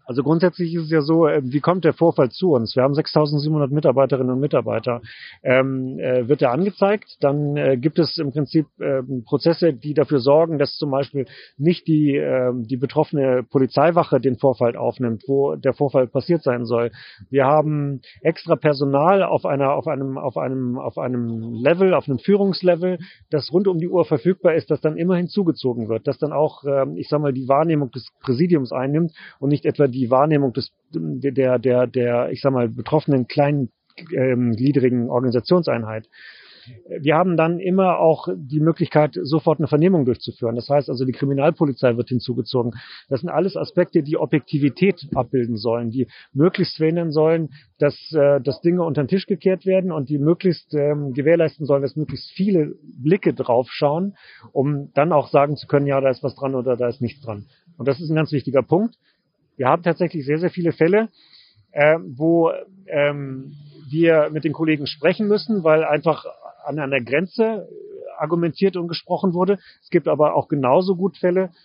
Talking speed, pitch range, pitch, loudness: 180 wpm, 135-165 Hz, 145 Hz, -20 LUFS